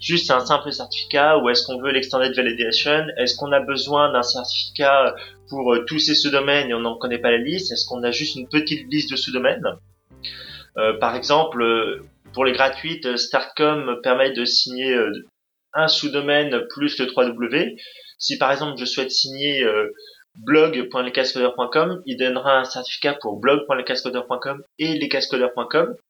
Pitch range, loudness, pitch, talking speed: 125-150 Hz, -20 LUFS, 135 Hz, 150 wpm